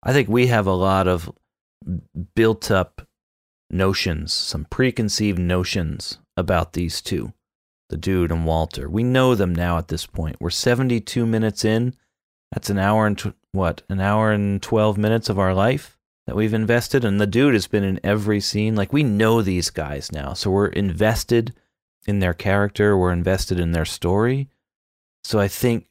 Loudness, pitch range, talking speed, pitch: -21 LUFS, 90-110 Hz, 175 wpm, 100 Hz